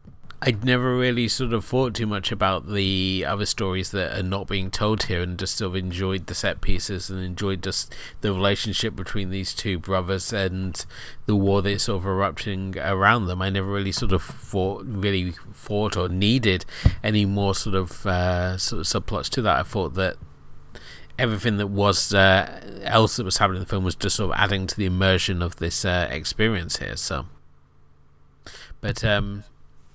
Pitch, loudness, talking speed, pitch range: 95 Hz, -23 LUFS, 190 wpm, 90-105 Hz